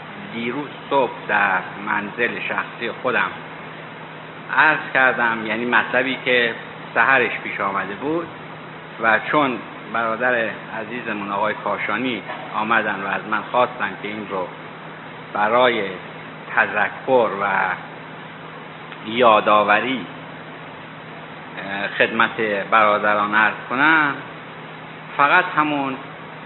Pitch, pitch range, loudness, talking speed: 115 Hz, 105-140 Hz, -19 LUFS, 90 wpm